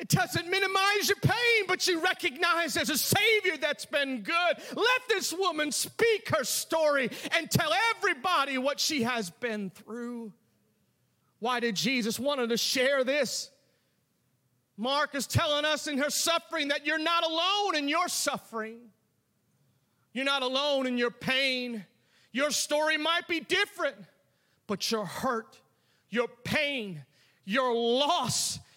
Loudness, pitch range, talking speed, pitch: -28 LUFS, 240-335 Hz, 140 wpm, 285 Hz